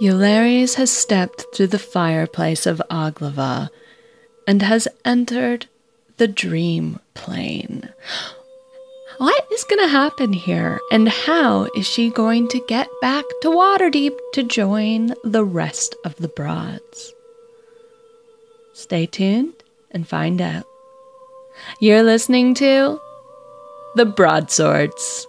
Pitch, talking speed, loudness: 245 Hz, 110 wpm, -18 LUFS